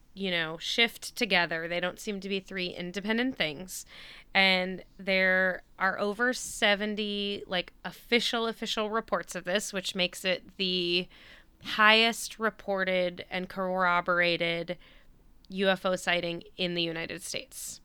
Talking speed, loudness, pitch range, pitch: 125 wpm, -28 LUFS, 180-210 Hz, 190 Hz